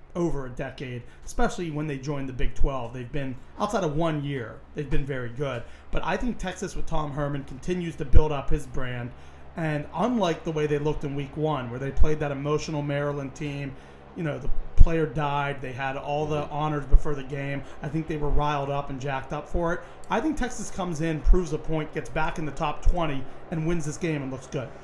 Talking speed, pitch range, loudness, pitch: 225 wpm, 140-160 Hz, -29 LUFS, 150 Hz